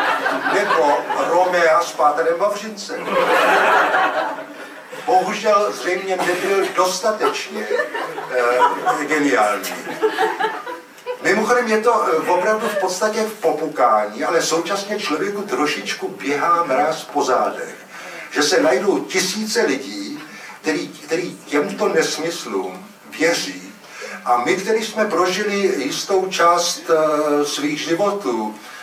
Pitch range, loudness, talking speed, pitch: 165-220 Hz, -18 LUFS, 100 wpm, 195 Hz